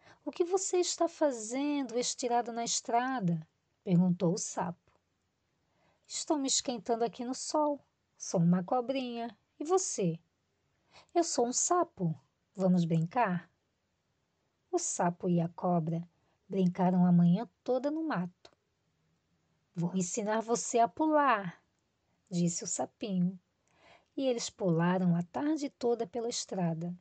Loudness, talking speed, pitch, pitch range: -32 LUFS, 120 wpm, 225 Hz, 175-265 Hz